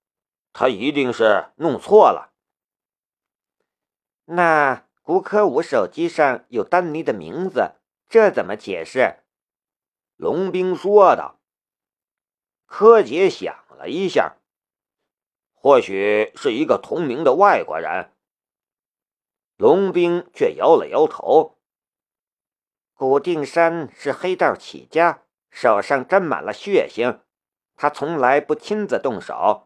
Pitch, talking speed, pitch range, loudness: 185 Hz, 155 characters per minute, 155-230 Hz, -18 LUFS